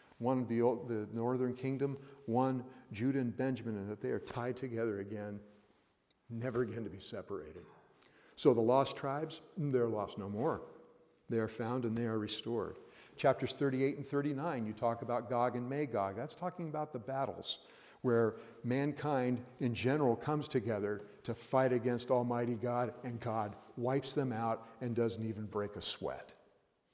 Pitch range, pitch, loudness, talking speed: 115-135 Hz, 125 Hz, -37 LUFS, 165 wpm